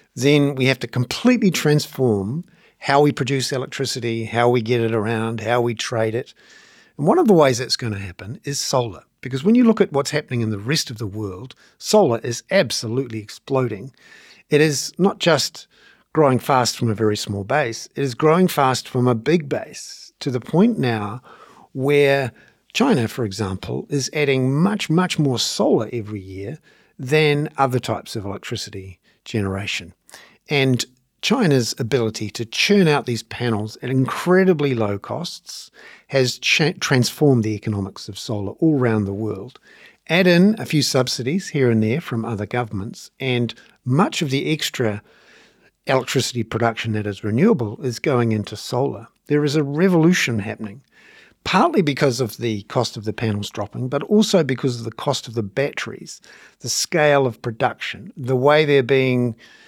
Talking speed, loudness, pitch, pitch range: 170 wpm, -20 LUFS, 125 Hz, 115-145 Hz